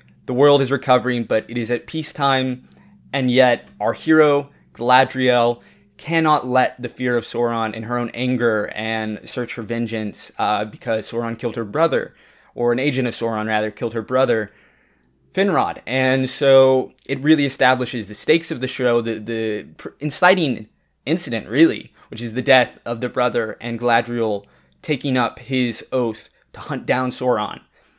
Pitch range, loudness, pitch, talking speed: 115-130 Hz, -19 LUFS, 125 Hz, 165 wpm